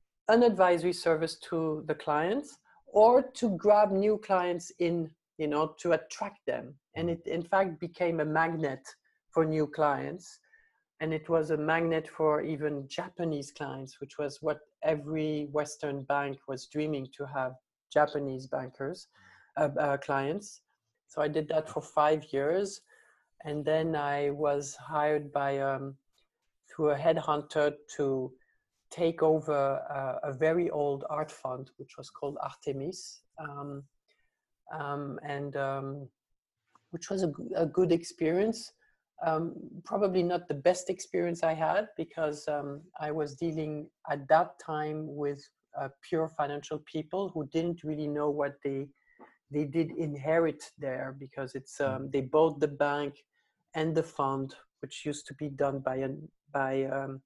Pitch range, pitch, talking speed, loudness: 140-165 Hz, 150 Hz, 150 wpm, -31 LUFS